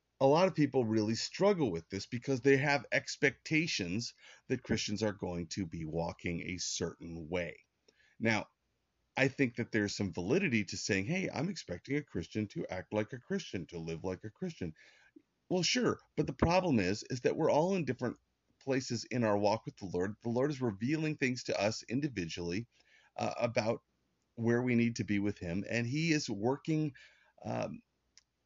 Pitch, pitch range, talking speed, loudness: 115 Hz, 100-140 Hz, 185 wpm, -34 LUFS